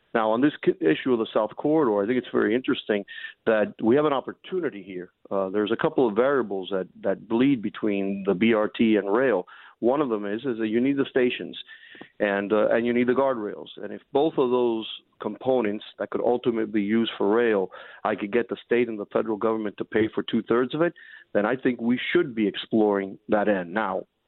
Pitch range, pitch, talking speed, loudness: 105-125 Hz, 115 Hz, 220 wpm, -25 LUFS